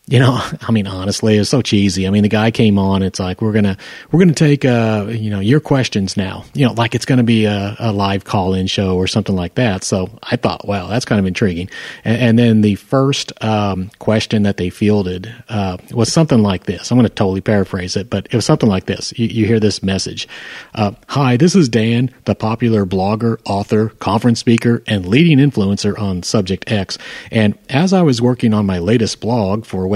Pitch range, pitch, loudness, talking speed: 100-120 Hz, 110 Hz, -15 LUFS, 225 wpm